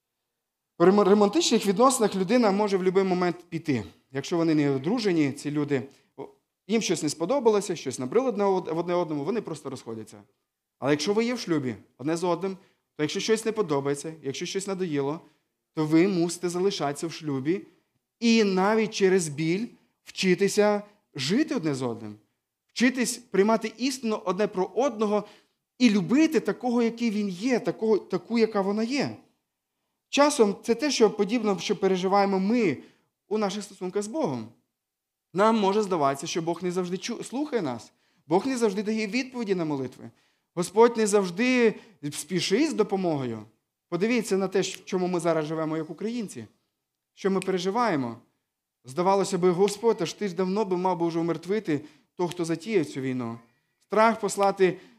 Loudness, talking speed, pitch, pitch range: -26 LUFS, 155 wpm, 190 Hz, 160-215 Hz